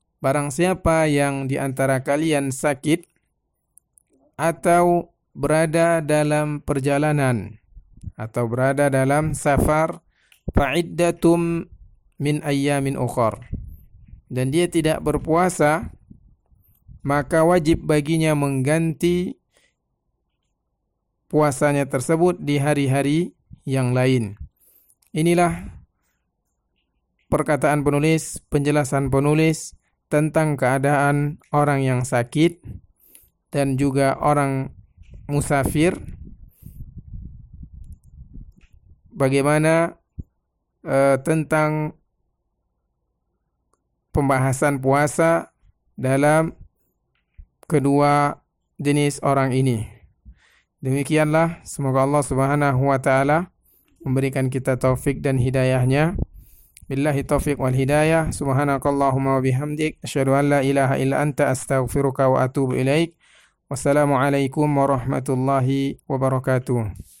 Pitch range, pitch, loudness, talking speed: 130-155 Hz, 140 Hz, -20 LUFS, 80 wpm